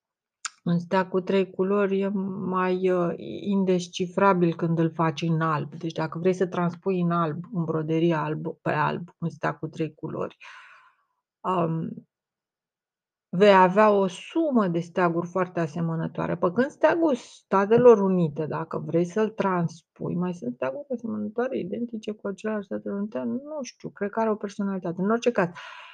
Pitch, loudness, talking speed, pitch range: 185 Hz, -25 LUFS, 155 wpm, 165-215 Hz